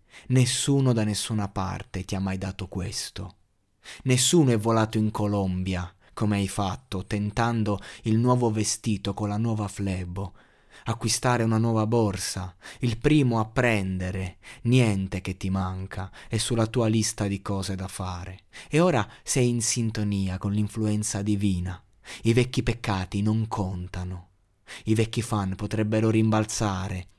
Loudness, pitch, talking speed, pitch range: -26 LUFS, 105 Hz, 140 wpm, 95-115 Hz